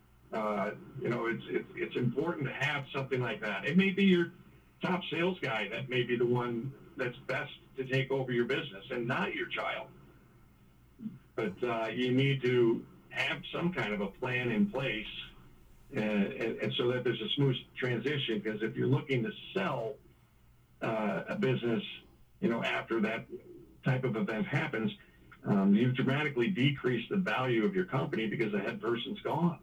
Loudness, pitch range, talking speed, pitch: -33 LUFS, 115-145 Hz, 175 wpm, 130 Hz